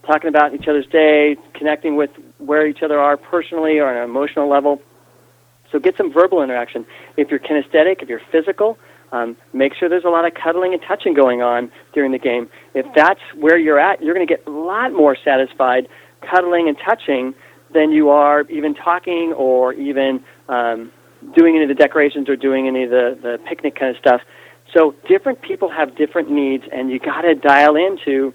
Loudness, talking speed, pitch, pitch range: -16 LUFS, 200 wpm, 145 Hz, 135-165 Hz